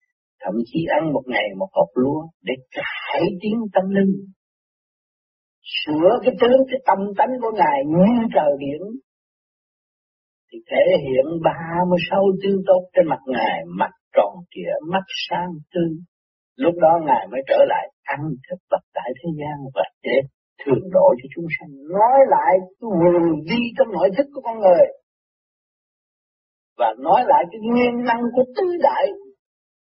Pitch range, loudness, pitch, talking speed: 165-265 Hz, -19 LUFS, 195 Hz, 160 wpm